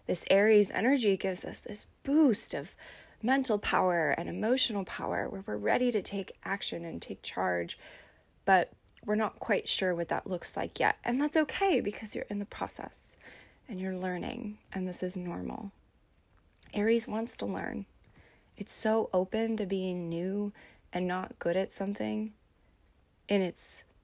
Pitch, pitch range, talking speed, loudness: 205 Hz, 185-225 Hz, 160 wpm, -30 LUFS